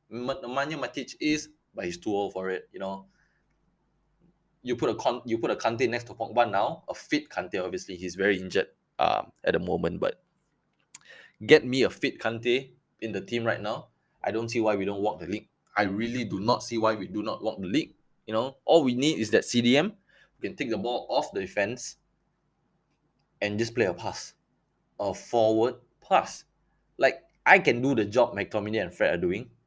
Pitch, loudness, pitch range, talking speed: 120 Hz, -27 LUFS, 105-140 Hz, 205 wpm